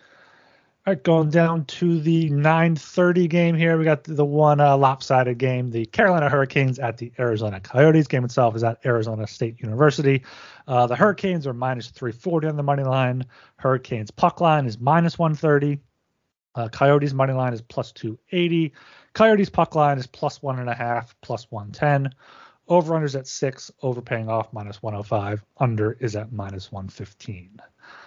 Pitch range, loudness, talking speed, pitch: 115-155 Hz, -21 LUFS, 165 wpm, 135 Hz